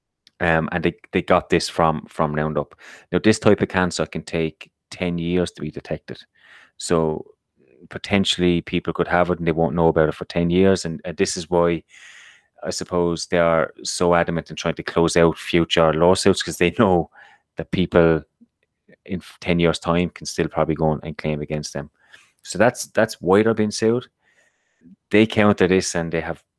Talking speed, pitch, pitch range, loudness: 190 wpm, 85 Hz, 80-90 Hz, -20 LUFS